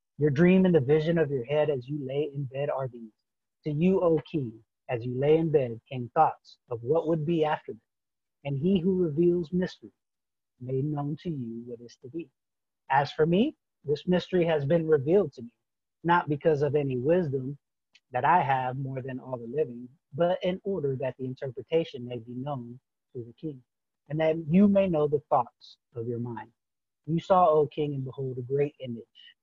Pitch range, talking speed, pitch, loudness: 125-165 Hz, 200 wpm, 145 Hz, -27 LUFS